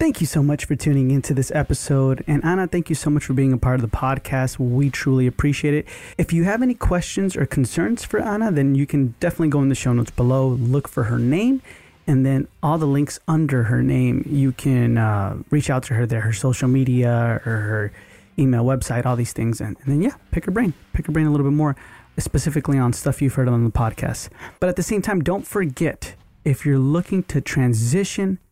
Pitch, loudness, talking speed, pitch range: 135 Hz, -20 LUFS, 230 wpm, 125-155 Hz